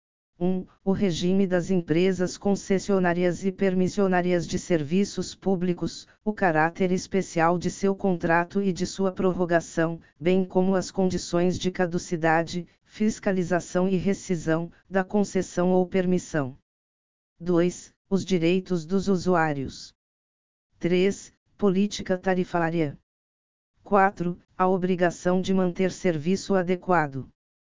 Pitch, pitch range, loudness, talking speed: 180 Hz, 170-190 Hz, -25 LUFS, 110 wpm